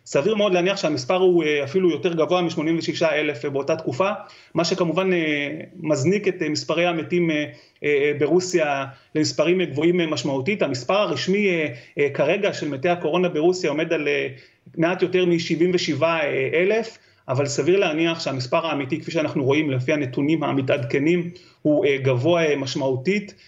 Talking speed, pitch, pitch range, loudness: 130 wpm, 165 Hz, 150-180 Hz, -21 LUFS